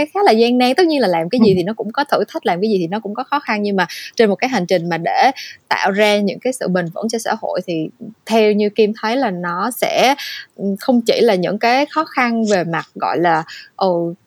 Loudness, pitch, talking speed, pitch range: -16 LUFS, 215 Hz, 275 wpm, 185-255 Hz